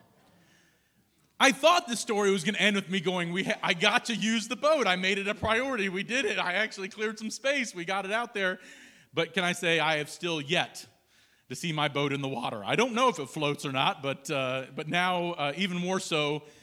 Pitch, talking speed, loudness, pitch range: 190 Hz, 245 wpm, -28 LUFS, 155-220 Hz